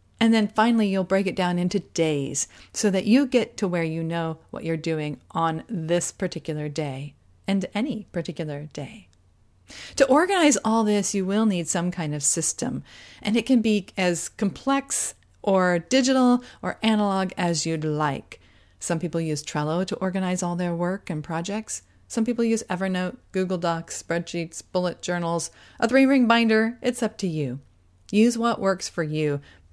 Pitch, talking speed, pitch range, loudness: 180 Hz, 170 wpm, 165-220 Hz, -24 LUFS